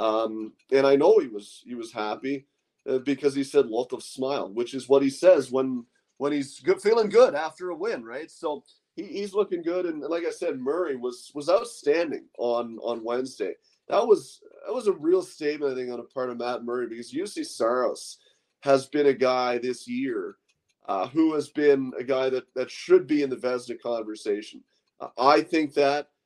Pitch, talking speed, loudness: 140 Hz, 205 wpm, -26 LUFS